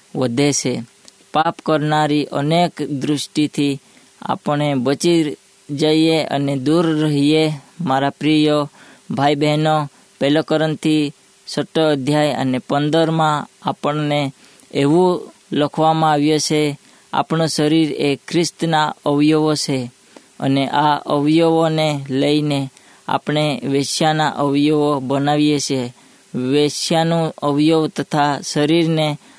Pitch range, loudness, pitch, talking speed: 145-155 Hz, -17 LUFS, 150 Hz, 90 wpm